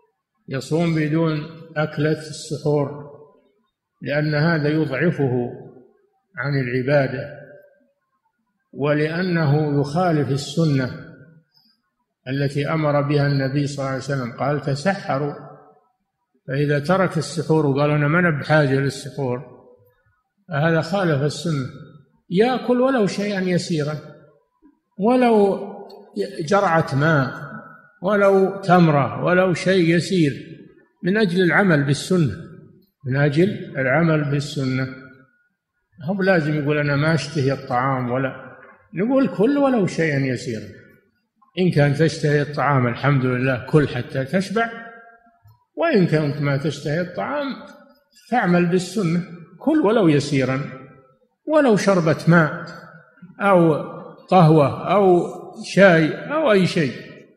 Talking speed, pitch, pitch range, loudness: 100 wpm, 160 Hz, 145-195 Hz, -20 LUFS